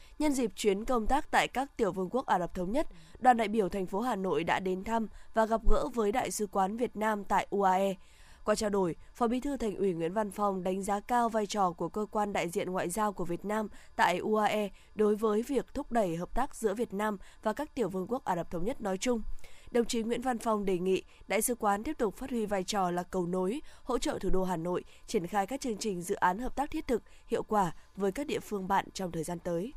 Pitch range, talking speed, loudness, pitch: 190-235 Hz, 265 wpm, -32 LUFS, 210 Hz